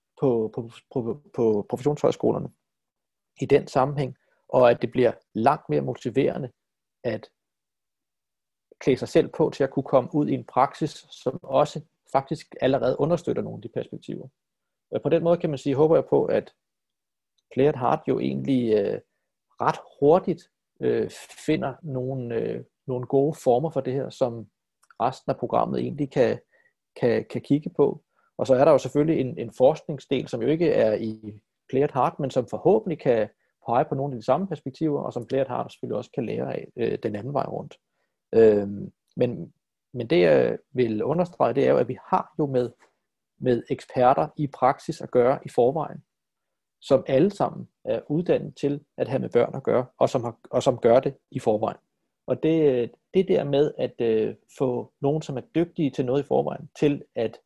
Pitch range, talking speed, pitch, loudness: 125-150 Hz, 185 wpm, 135 Hz, -24 LUFS